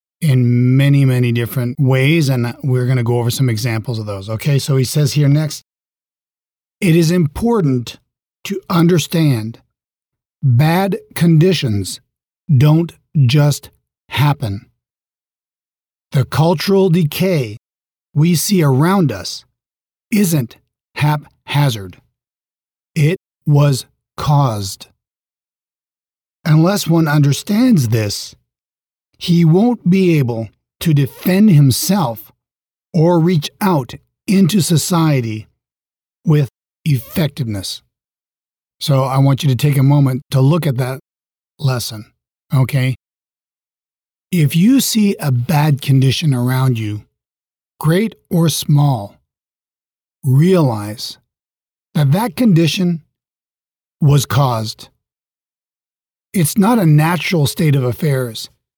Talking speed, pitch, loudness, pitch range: 100 wpm, 140 Hz, -15 LUFS, 120-165 Hz